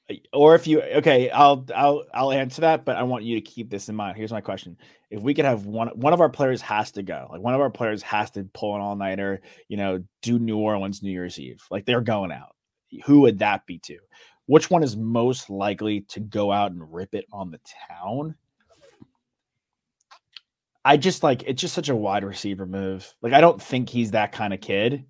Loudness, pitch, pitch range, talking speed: -22 LUFS, 110 Hz, 100-135 Hz, 220 wpm